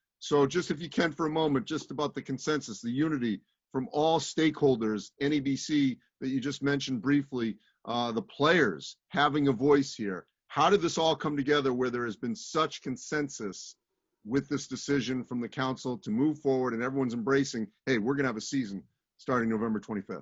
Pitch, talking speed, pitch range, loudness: 135 Hz, 190 wpm, 125-150 Hz, -30 LUFS